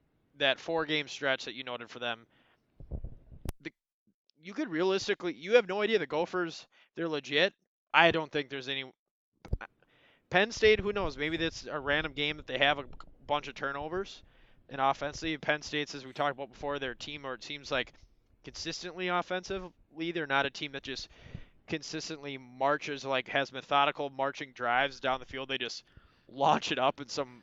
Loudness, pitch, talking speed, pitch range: -32 LUFS, 145 Hz, 180 wpm, 135-165 Hz